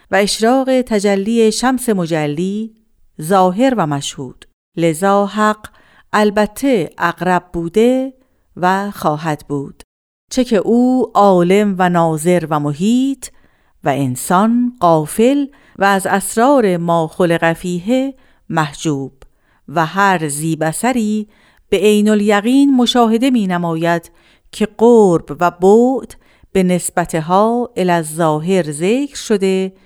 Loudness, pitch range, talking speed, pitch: -15 LUFS, 170-225 Hz, 105 wpm, 195 Hz